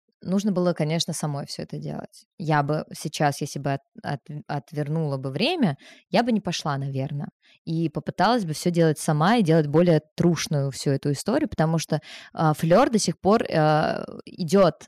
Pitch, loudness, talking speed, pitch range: 165 Hz, -24 LUFS, 175 wpm, 150-195 Hz